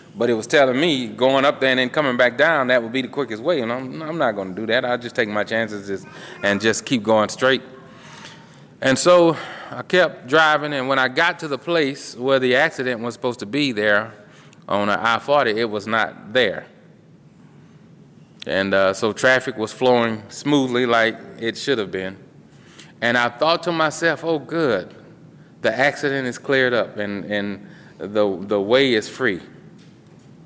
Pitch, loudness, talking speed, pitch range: 125 Hz, -19 LUFS, 190 wpm, 110-135 Hz